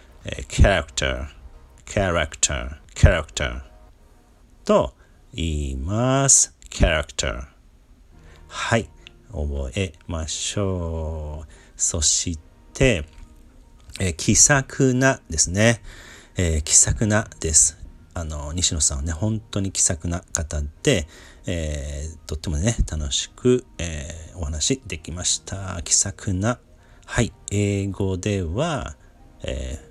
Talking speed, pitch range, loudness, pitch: 210 characters per minute, 80-100 Hz, -21 LUFS, 85 Hz